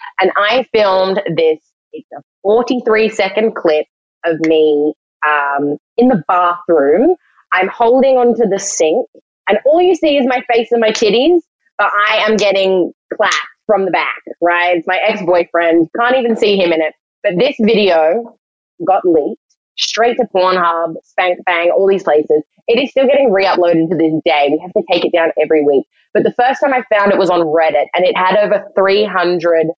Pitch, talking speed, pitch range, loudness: 195 Hz, 185 wpm, 170-235 Hz, -13 LUFS